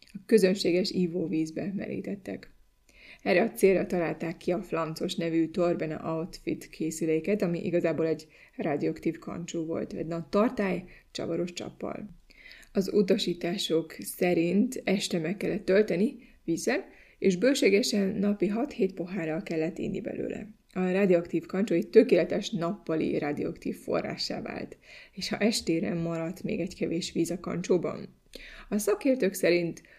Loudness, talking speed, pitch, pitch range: -29 LUFS, 125 wpm, 180 Hz, 165-205 Hz